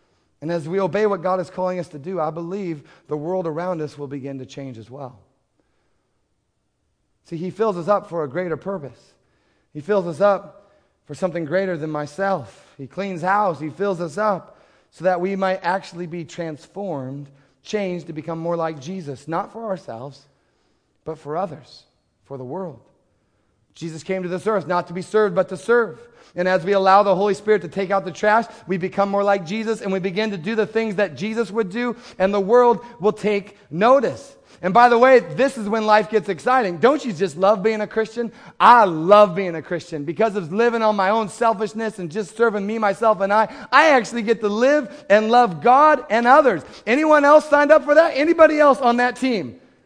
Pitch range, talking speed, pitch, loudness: 170-220 Hz, 210 wpm, 195 Hz, -19 LUFS